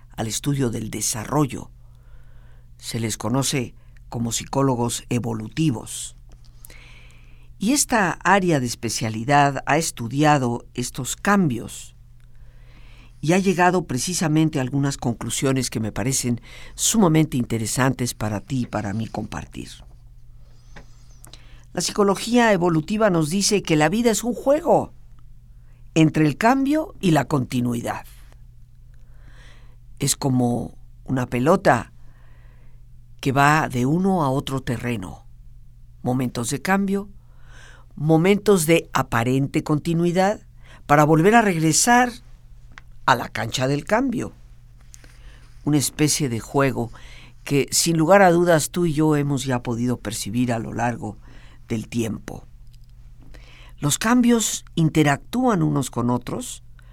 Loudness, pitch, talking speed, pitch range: -21 LUFS, 125 Hz, 115 wpm, 120-155 Hz